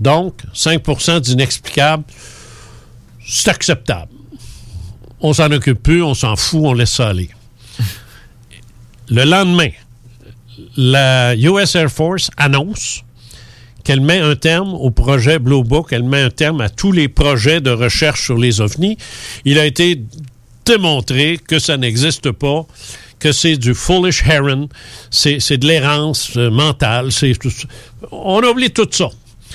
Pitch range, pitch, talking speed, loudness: 120-155 Hz, 135 Hz, 140 wpm, -13 LUFS